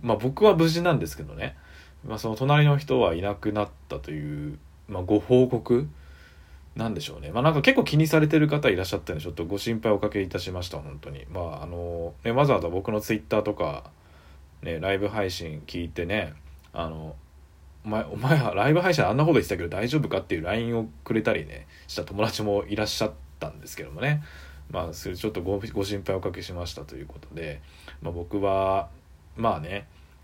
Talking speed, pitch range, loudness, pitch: 405 characters per minute, 75-110 Hz, -26 LUFS, 90 Hz